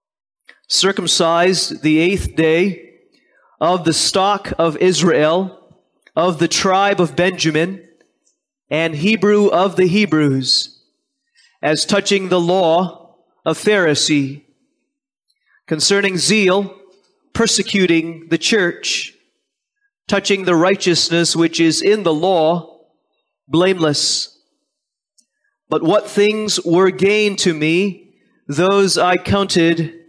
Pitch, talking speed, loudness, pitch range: 180 Hz, 100 wpm, -15 LUFS, 165-200 Hz